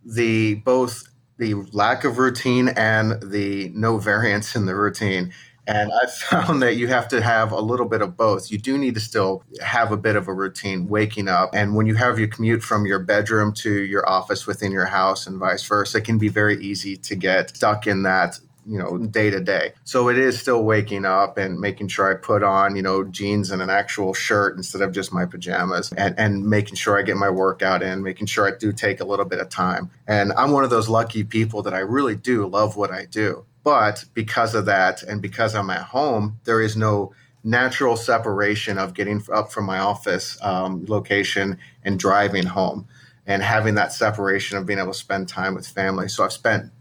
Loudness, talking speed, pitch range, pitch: -21 LUFS, 220 wpm, 100-110 Hz, 105 Hz